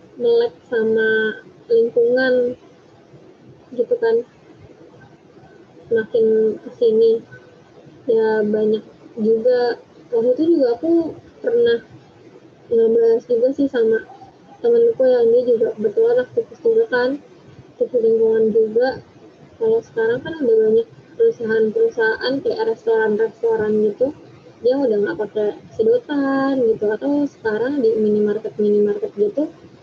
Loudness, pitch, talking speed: -18 LUFS, 290 Hz, 100 wpm